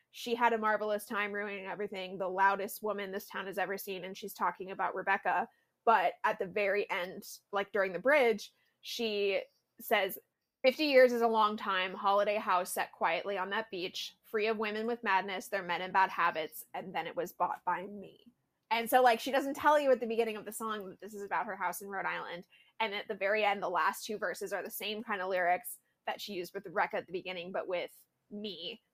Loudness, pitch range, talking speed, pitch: -33 LUFS, 190-220 Hz, 225 wpm, 200 Hz